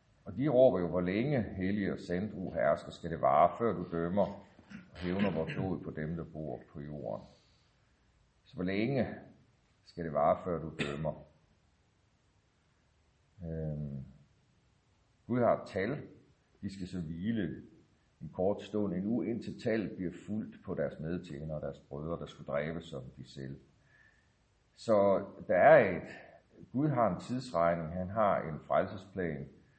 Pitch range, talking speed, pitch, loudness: 75-100 Hz, 150 wpm, 85 Hz, -33 LUFS